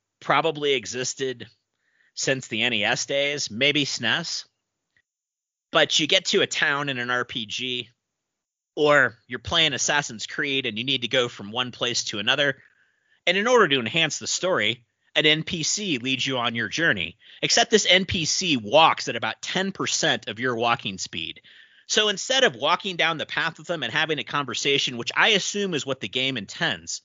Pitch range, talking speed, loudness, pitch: 120-160 Hz, 175 wpm, -22 LUFS, 135 Hz